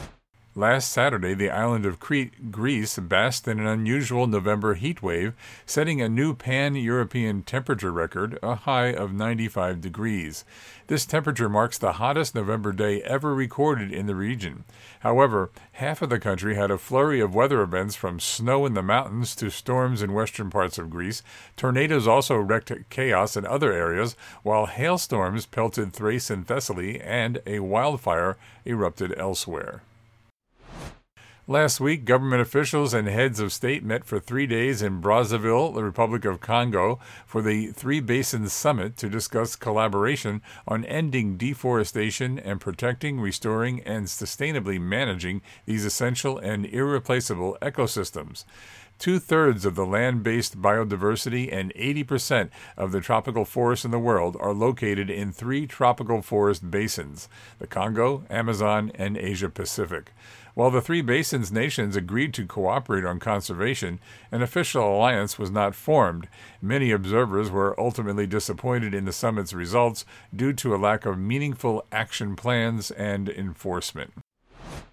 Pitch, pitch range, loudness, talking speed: 110 Hz, 100-125 Hz, -25 LUFS, 145 wpm